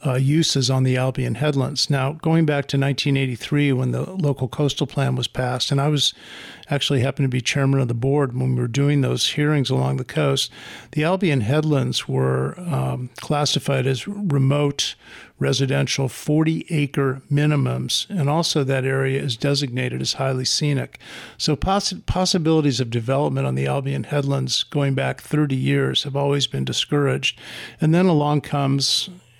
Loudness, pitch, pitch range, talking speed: -21 LUFS, 140 Hz, 130-145 Hz, 165 wpm